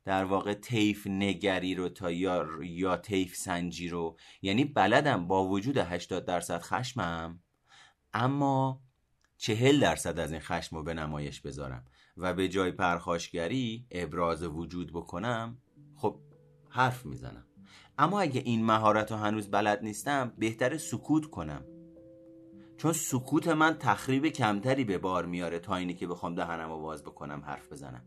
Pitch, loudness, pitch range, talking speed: 95 Hz, -31 LUFS, 85-130 Hz, 140 wpm